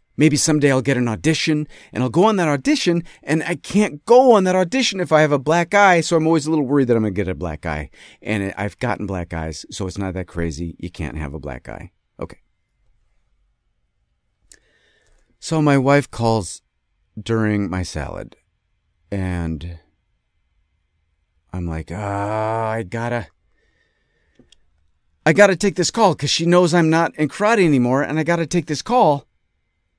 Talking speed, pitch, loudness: 180 wpm, 115 Hz, -18 LUFS